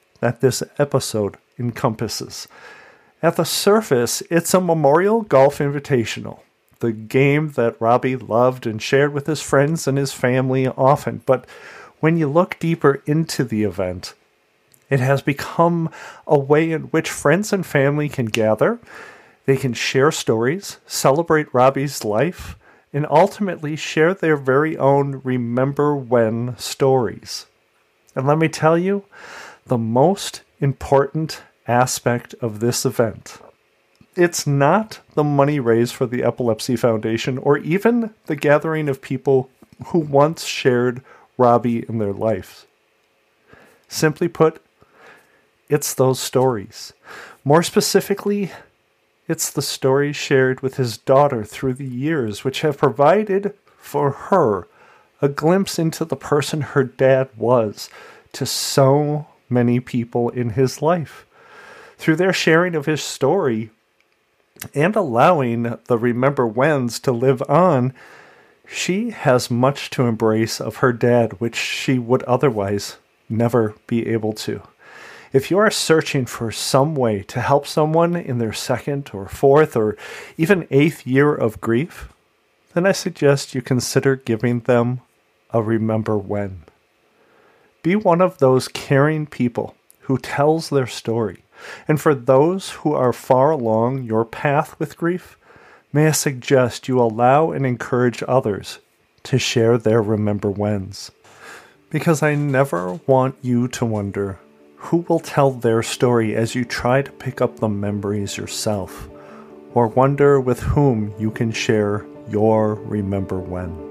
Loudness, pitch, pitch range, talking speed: -19 LUFS, 135 Hz, 115-155 Hz, 135 wpm